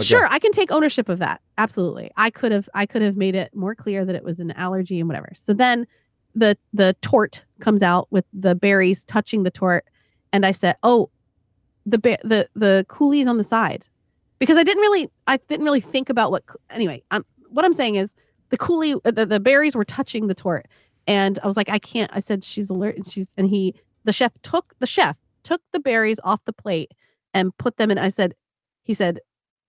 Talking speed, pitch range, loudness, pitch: 220 wpm, 190-245 Hz, -20 LUFS, 210 Hz